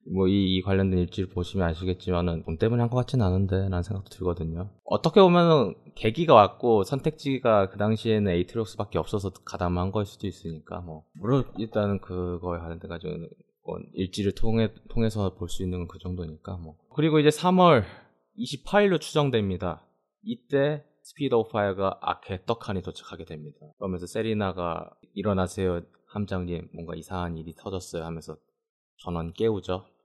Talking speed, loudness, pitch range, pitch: 360 characters per minute, -26 LUFS, 90-115 Hz, 95 Hz